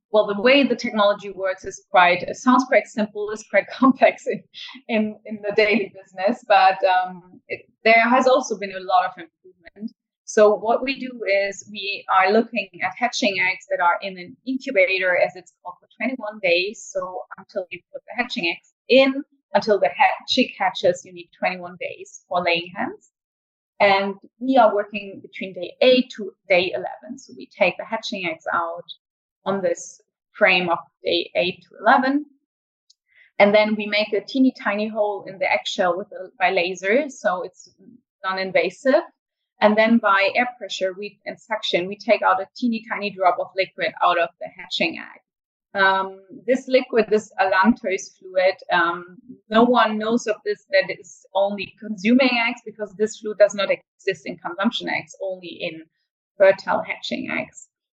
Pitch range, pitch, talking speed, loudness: 190-245 Hz, 210 Hz, 175 wpm, -21 LUFS